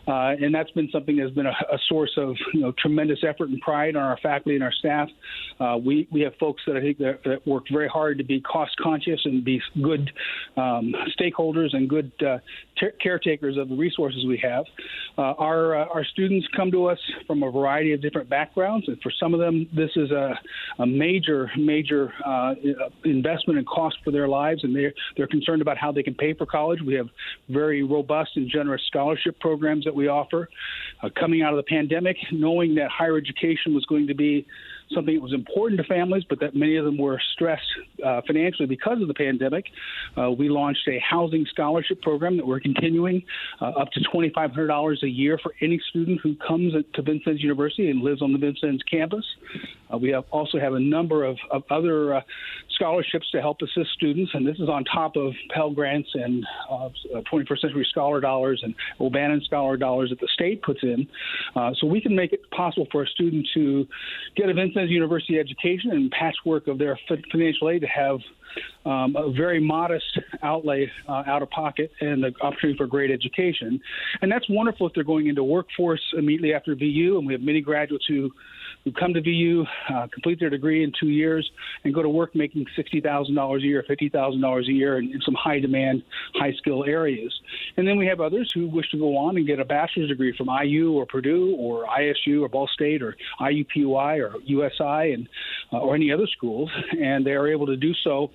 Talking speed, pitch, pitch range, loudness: 205 wpm, 150 Hz, 140-165 Hz, -24 LUFS